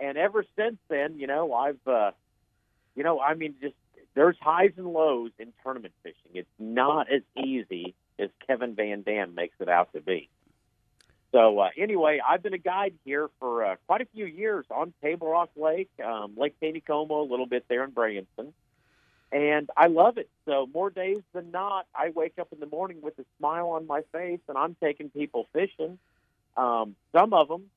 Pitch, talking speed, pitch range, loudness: 150 Hz, 195 wpm, 125-170 Hz, -27 LUFS